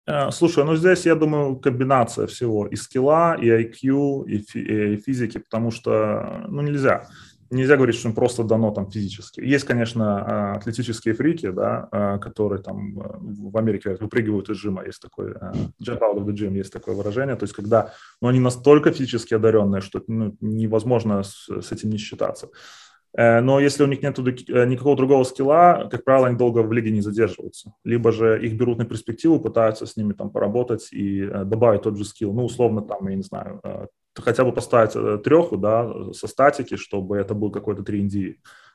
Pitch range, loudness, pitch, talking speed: 105-125 Hz, -21 LUFS, 115 Hz, 175 wpm